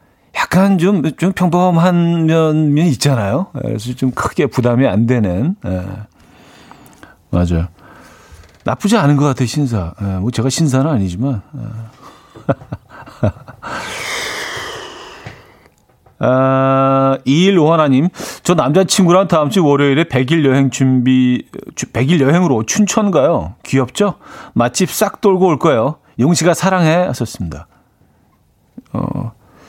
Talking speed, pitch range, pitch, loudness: 220 characters per minute, 120-170 Hz, 135 Hz, -14 LUFS